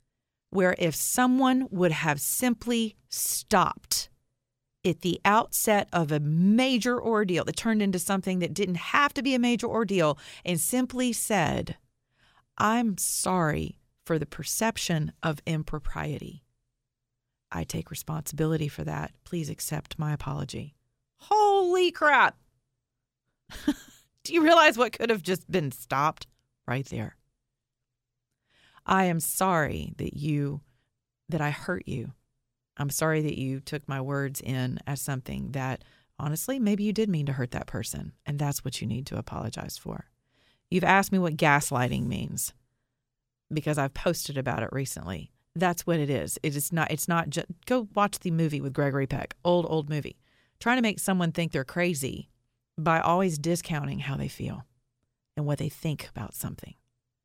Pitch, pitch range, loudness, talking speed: 150 Hz, 130-185 Hz, -27 LUFS, 155 wpm